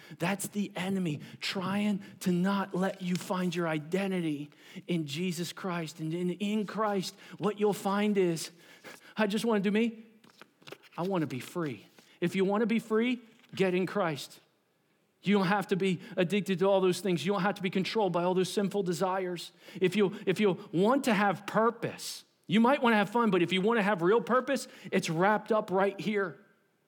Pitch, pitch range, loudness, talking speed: 195 Hz, 180-210 Hz, -30 LUFS, 200 wpm